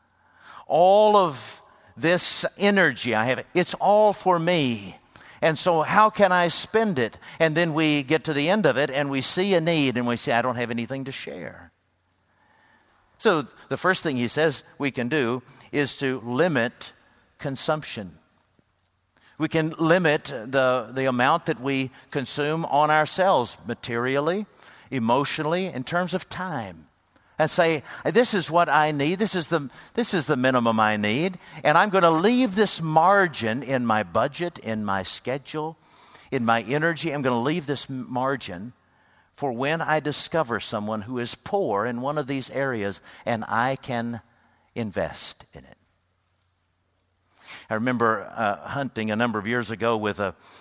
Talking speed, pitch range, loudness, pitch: 165 wpm, 115-165 Hz, -23 LUFS, 135 Hz